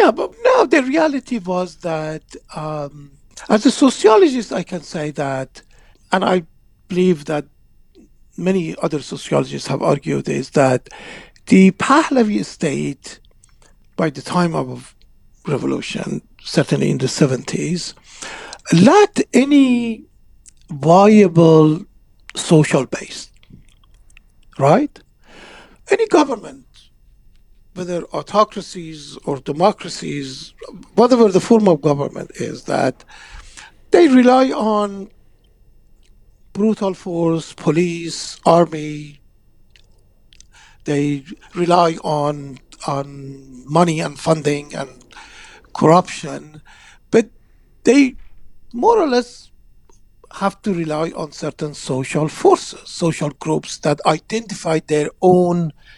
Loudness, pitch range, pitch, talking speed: -17 LUFS, 145-215 Hz, 170 Hz, 100 wpm